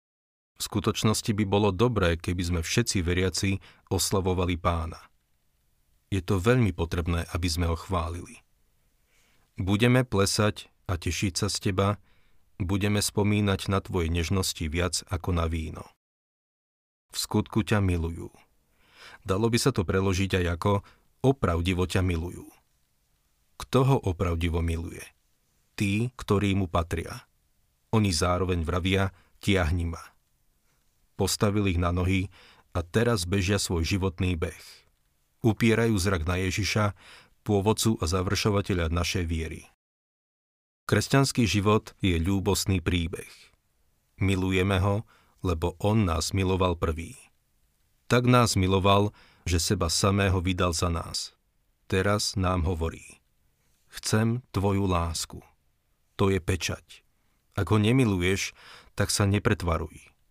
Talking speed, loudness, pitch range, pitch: 115 wpm, -27 LUFS, 85-105 Hz, 95 Hz